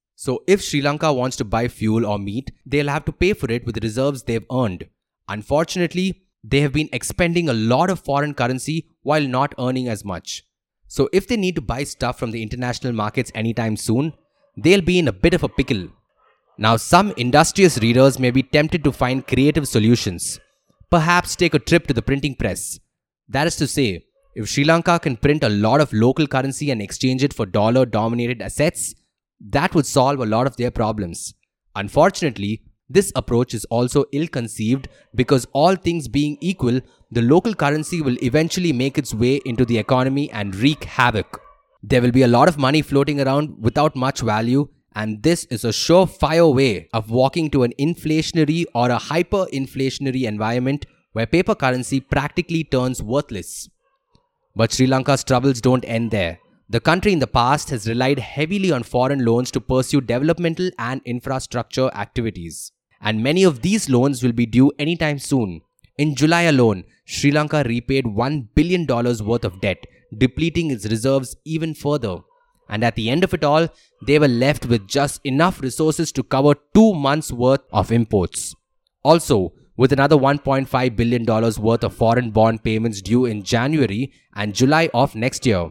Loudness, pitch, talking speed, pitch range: -19 LUFS, 130 Hz, 175 wpm, 115-150 Hz